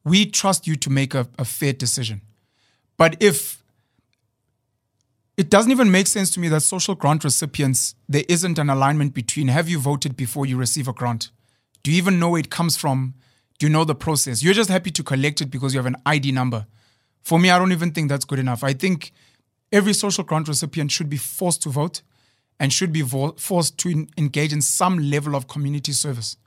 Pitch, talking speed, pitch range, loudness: 145 Hz, 210 wpm, 130-165 Hz, -20 LUFS